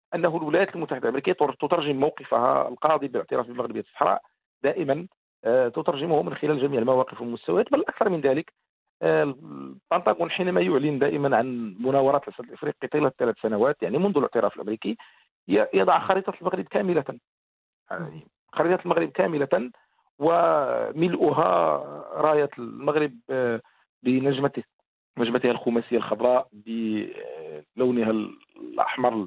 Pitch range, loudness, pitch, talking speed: 120-170 Hz, -25 LUFS, 135 Hz, 110 wpm